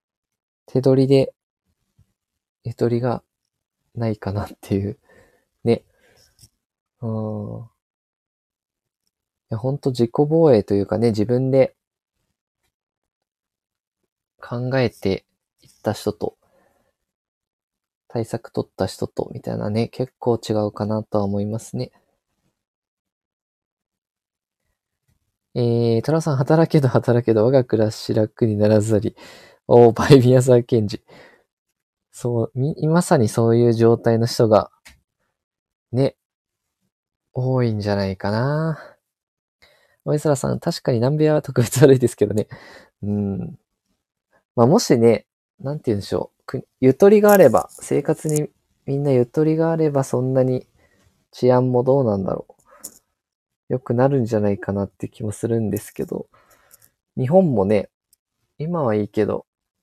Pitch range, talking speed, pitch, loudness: 105-135 Hz, 230 characters per minute, 120 Hz, -19 LUFS